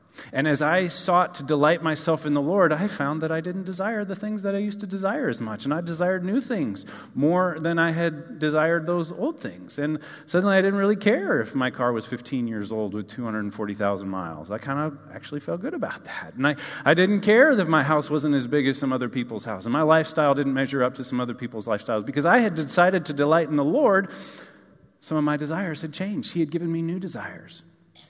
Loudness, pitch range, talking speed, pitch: -24 LUFS, 135-180 Hz, 235 wpm, 155 Hz